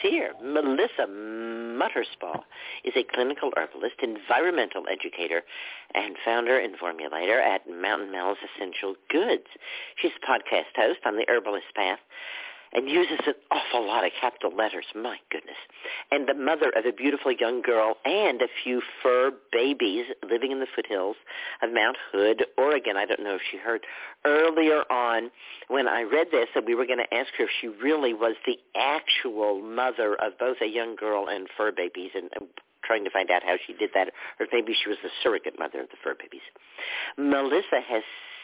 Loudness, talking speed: -26 LUFS, 180 wpm